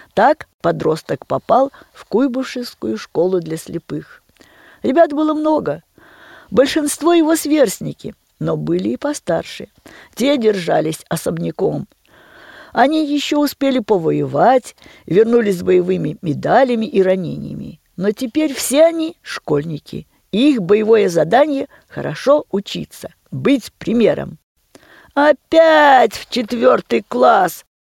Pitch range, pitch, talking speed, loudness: 205-305 Hz, 265 Hz, 100 wpm, -16 LUFS